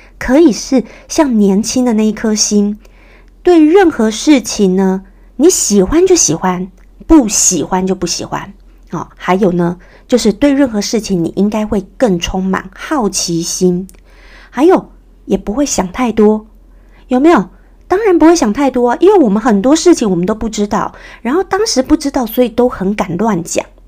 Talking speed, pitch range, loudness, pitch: 245 characters per minute, 195-280 Hz, -12 LUFS, 220 Hz